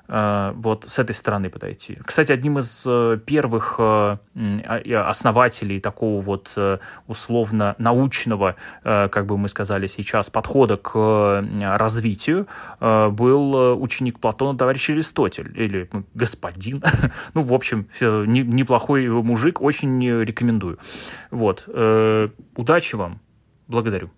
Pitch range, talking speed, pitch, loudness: 105-130 Hz, 95 wpm, 115 Hz, -20 LUFS